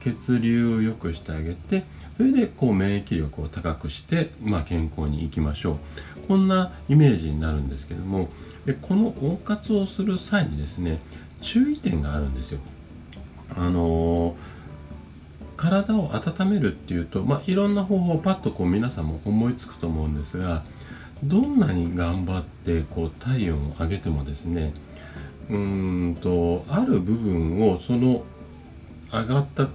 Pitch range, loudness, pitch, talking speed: 80-130 Hz, -24 LUFS, 85 Hz, 300 characters per minute